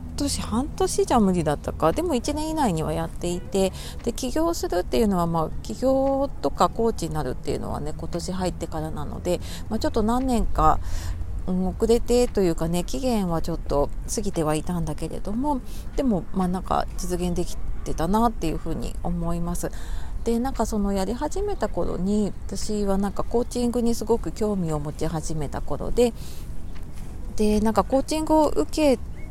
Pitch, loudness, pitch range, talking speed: 185 Hz, -25 LUFS, 160-235 Hz, 355 characters per minute